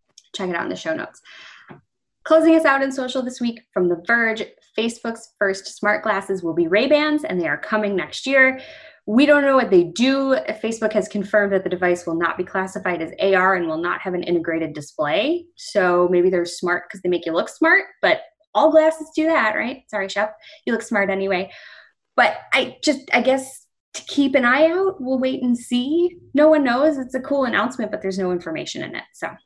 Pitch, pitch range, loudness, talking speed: 230 Hz, 190-290 Hz, -20 LUFS, 215 wpm